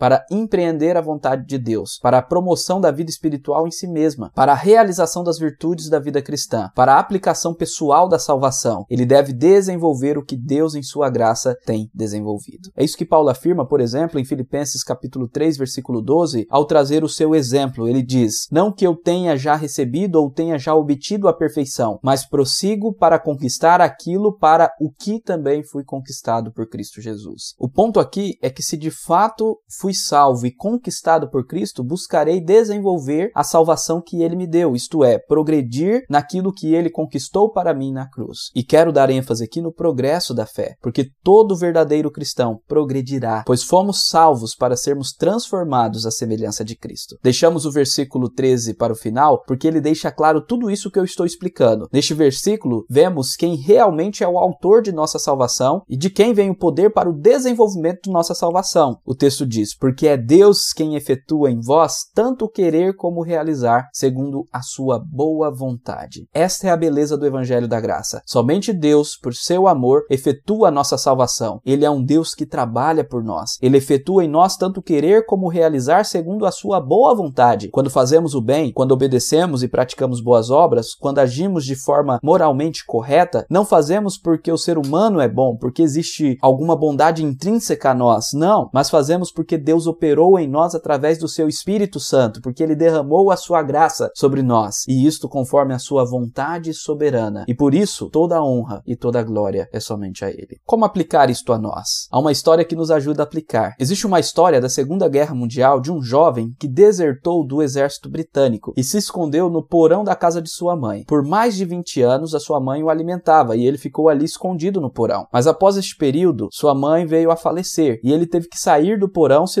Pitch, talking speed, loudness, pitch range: 155 Hz, 195 wpm, -17 LUFS, 130-170 Hz